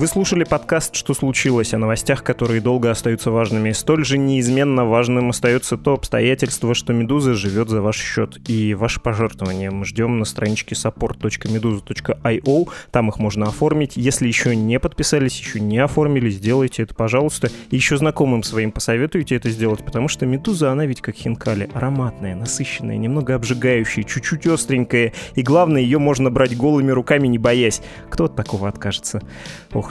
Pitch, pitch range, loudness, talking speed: 125 Hz, 115-140 Hz, -19 LUFS, 160 wpm